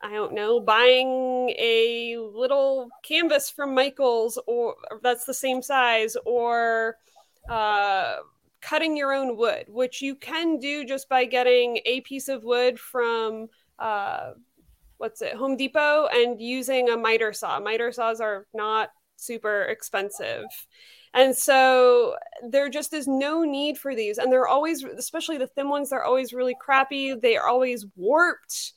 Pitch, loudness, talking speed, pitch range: 255 Hz, -23 LUFS, 150 wpm, 235-280 Hz